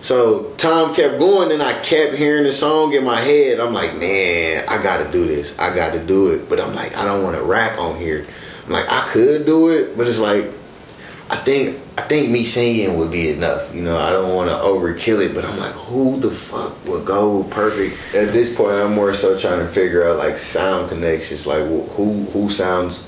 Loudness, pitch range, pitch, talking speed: -17 LUFS, 95-150 Hz, 105 Hz, 230 wpm